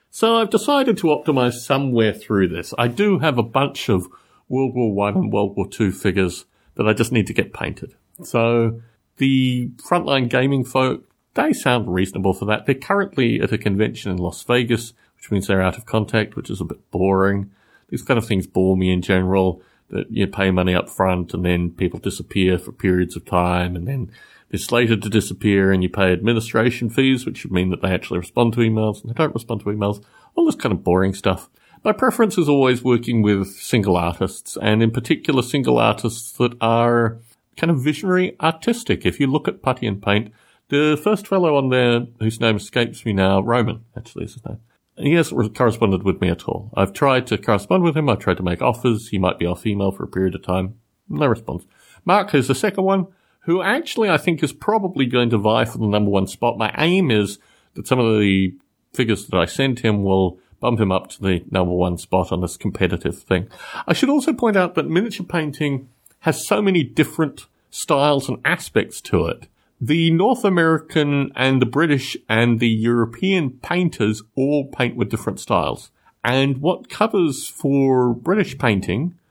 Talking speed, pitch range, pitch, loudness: 200 wpm, 100-140 Hz, 115 Hz, -19 LUFS